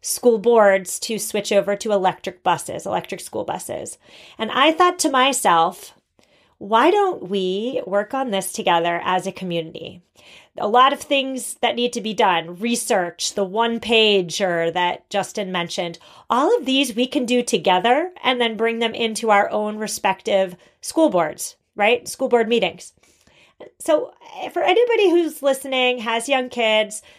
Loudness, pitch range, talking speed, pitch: -19 LUFS, 195-255 Hz, 155 wpm, 225 Hz